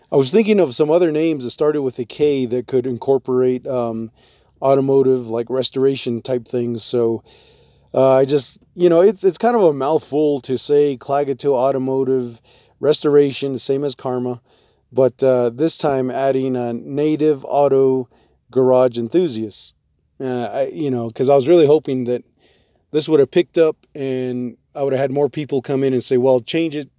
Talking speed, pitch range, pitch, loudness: 180 wpm, 125-145 Hz, 130 Hz, -18 LUFS